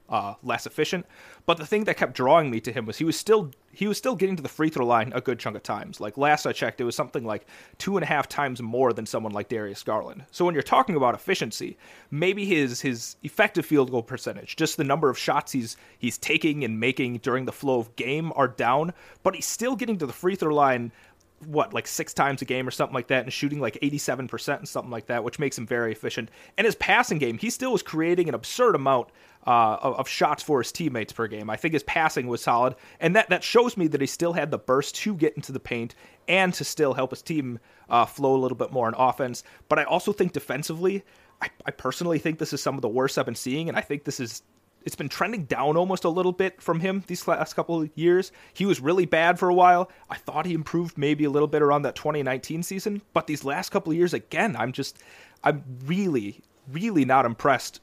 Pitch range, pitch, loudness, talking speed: 130-175 Hz, 150 Hz, -25 LUFS, 245 wpm